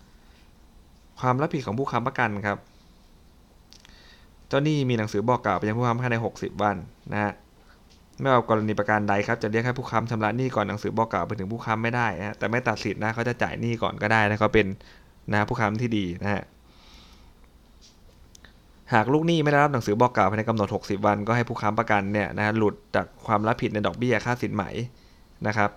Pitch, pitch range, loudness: 105 Hz, 100-120 Hz, -25 LUFS